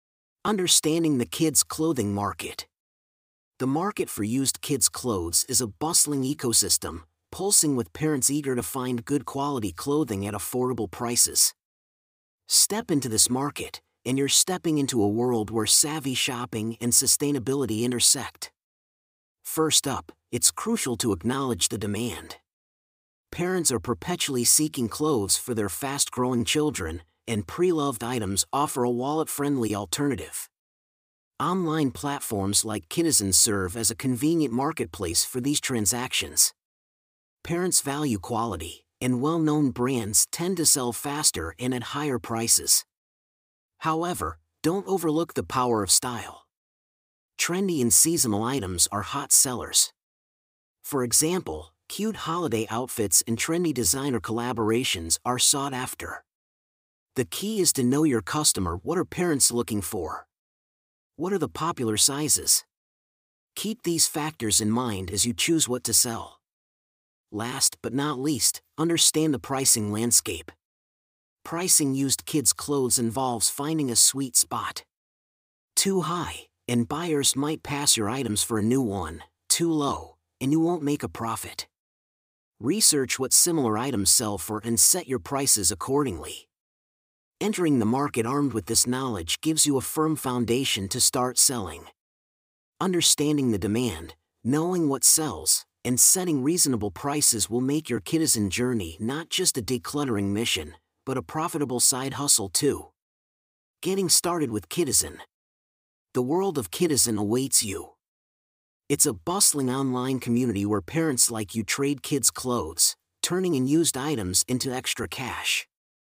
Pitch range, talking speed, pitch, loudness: 110-150 Hz, 135 wpm, 125 Hz, -23 LUFS